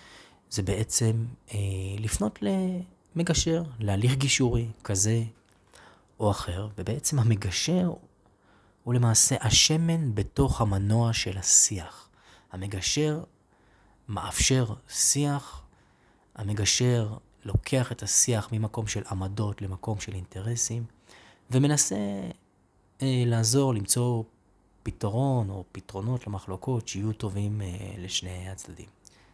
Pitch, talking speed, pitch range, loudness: 110 Hz, 90 wpm, 100-125 Hz, -26 LUFS